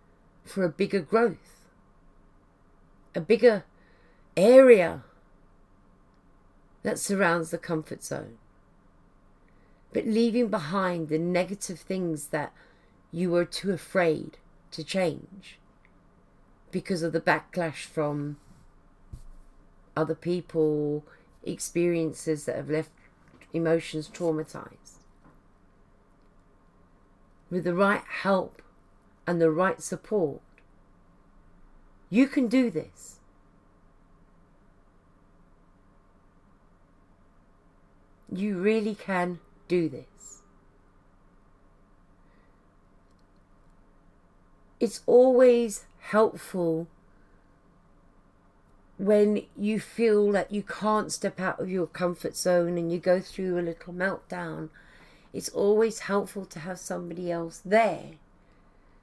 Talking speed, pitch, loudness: 85 wpm, 155 Hz, -27 LUFS